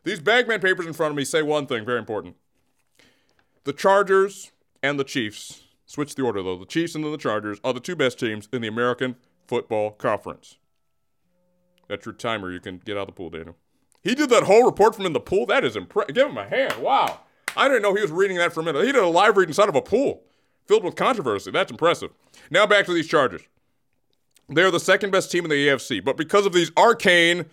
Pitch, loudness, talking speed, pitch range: 155 Hz, -21 LUFS, 235 wpm, 120-185 Hz